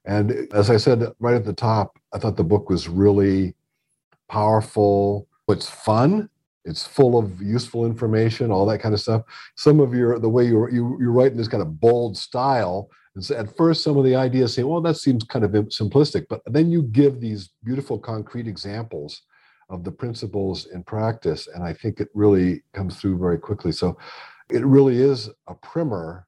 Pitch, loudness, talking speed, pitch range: 115 Hz, -21 LUFS, 190 wpm, 100-130 Hz